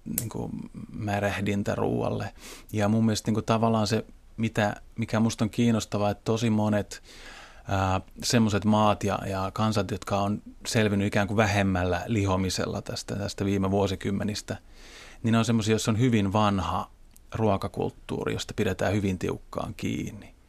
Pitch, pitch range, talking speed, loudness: 105 Hz, 100-110 Hz, 145 wpm, -27 LUFS